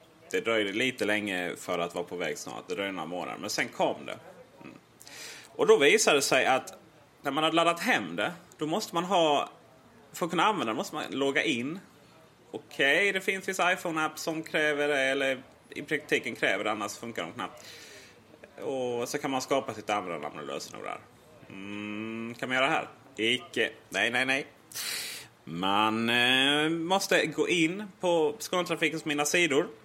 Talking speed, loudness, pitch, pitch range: 185 wpm, -28 LUFS, 145 Hz, 110-165 Hz